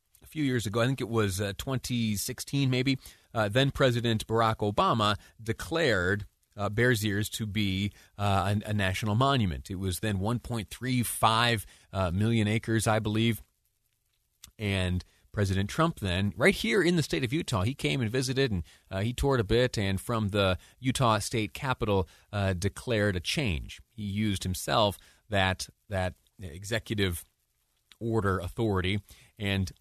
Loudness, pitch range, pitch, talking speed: -29 LUFS, 95-120 Hz, 105 Hz, 150 wpm